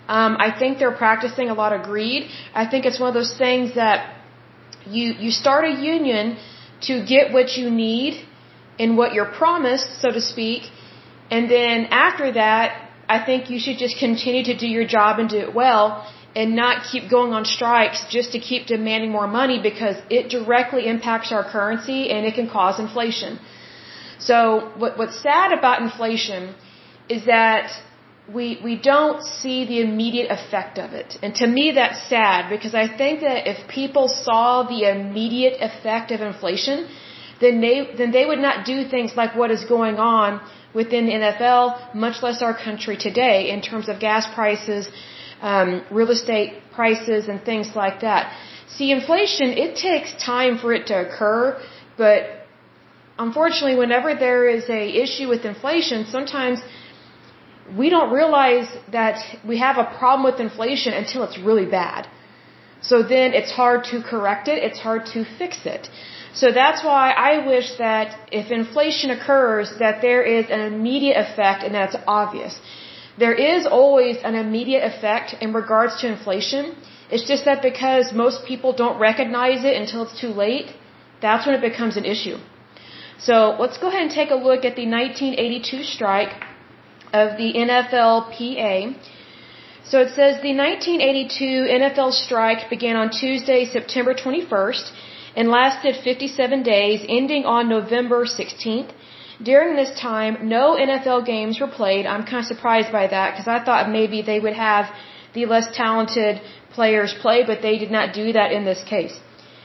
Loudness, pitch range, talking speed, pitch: -19 LUFS, 220-255 Hz, 165 wpm, 235 Hz